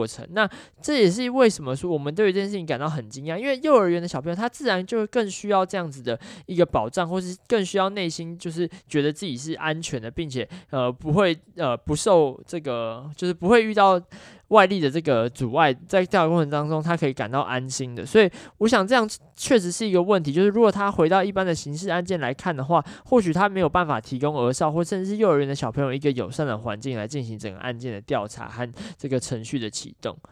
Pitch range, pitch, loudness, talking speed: 135-195 Hz, 170 Hz, -23 LUFS, 355 characters per minute